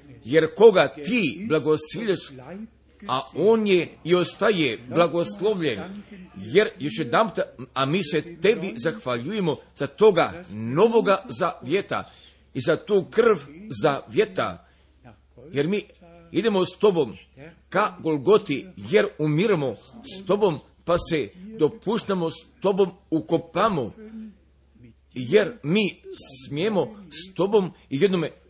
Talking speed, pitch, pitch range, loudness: 115 wpm, 185 Hz, 160-210 Hz, -23 LUFS